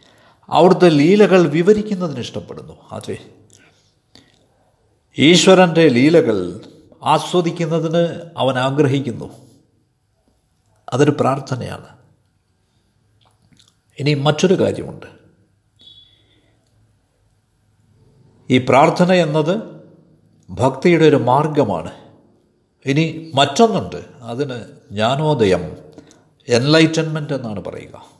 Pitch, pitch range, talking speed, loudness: 135 Hz, 110-160 Hz, 60 wpm, -15 LUFS